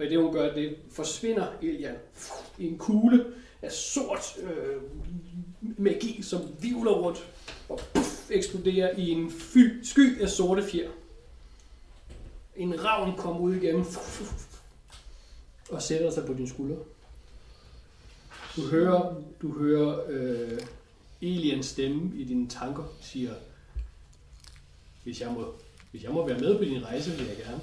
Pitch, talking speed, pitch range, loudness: 165 Hz, 145 wpm, 125-190 Hz, -29 LUFS